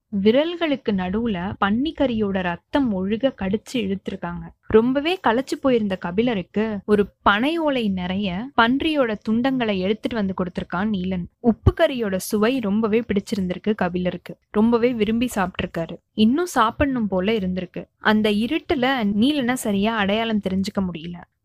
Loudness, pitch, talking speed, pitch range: -22 LUFS, 215 Hz, 115 wpm, 190-245 Hz